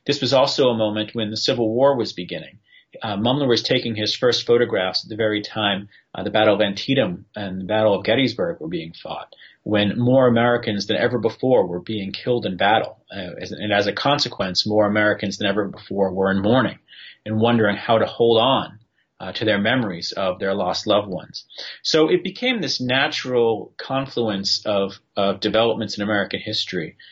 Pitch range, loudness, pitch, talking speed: 100-120 Hz, -20 LUFS, 110 Hz, 190 wpm